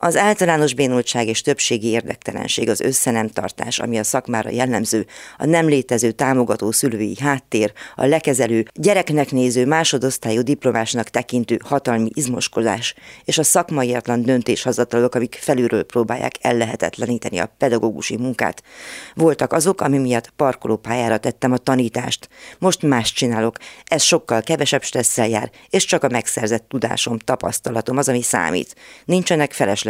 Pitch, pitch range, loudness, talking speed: 125 Hz, 115-145 Hz, -19 LUFS, 130 wpm